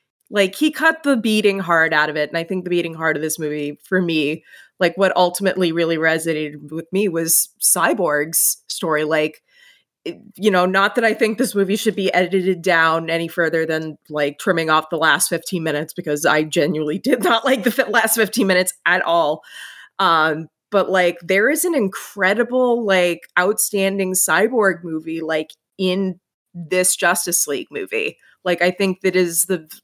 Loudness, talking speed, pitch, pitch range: -18 LUFS, 180 wpm, 180 Hz, 160-205 Hz